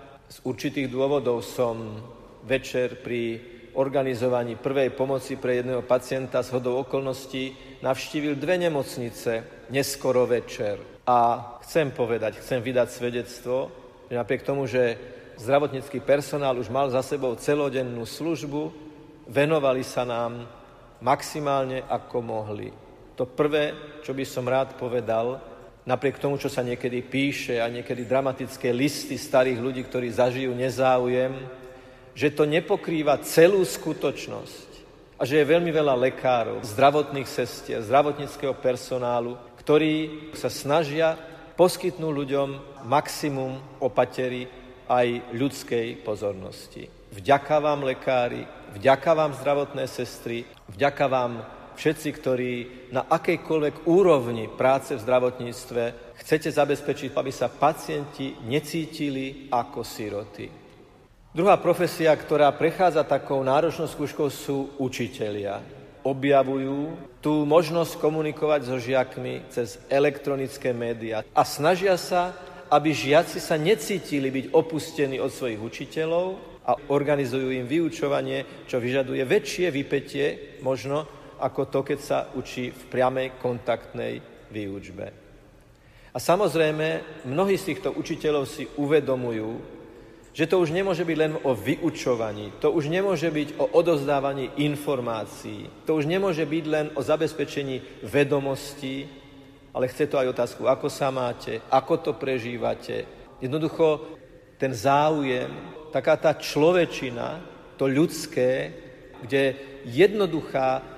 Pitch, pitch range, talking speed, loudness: 135 Hz, 125-150 Hz, 115 wpm, -25 LUFS